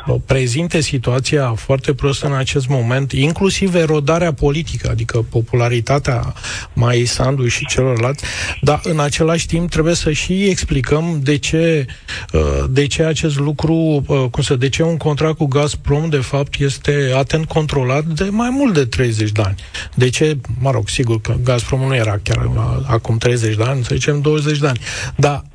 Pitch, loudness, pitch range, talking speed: 140 Hz, -16 LUFS, 125-155 Hz, 160 wpm